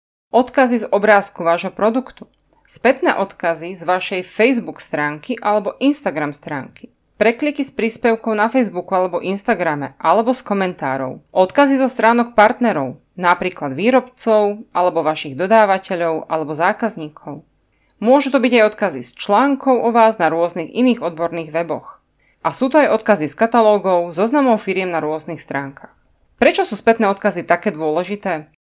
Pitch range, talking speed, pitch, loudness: 170-230 Hz, 140 wpm, 200 Hz, -17 LUFS